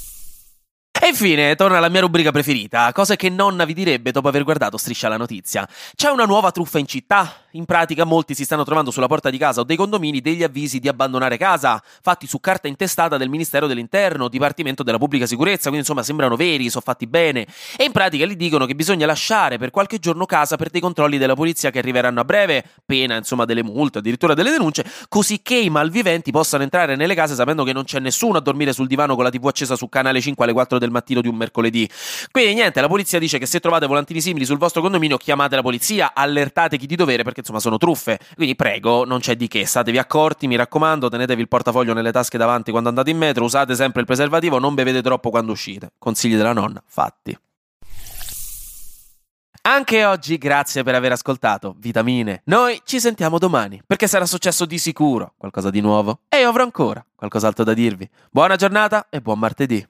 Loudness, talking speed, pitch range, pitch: -18 LUFS, 205 wpm, 125-170 Hz, 140 Hz